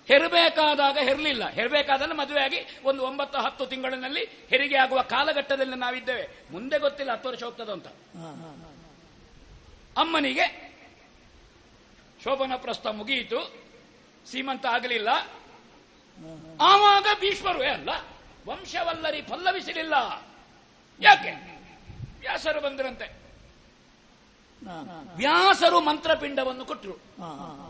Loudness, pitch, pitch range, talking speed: -24 LUFS, 280 Hz, 260-320 Hz, 75 wpm